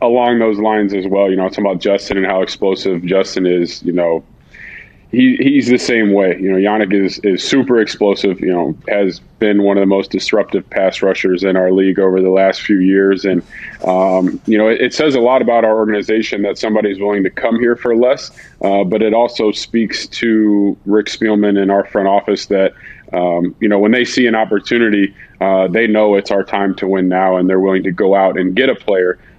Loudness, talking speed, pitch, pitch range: -13 LUFS, 220 wpm, 100 Hz, 95-110 Hz